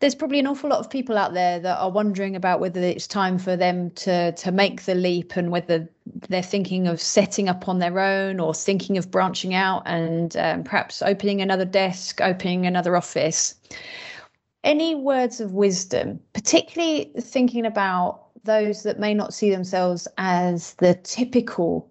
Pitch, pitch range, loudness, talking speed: 190 Hz, 180-210 Hz, -22 LUFS, 175 wpm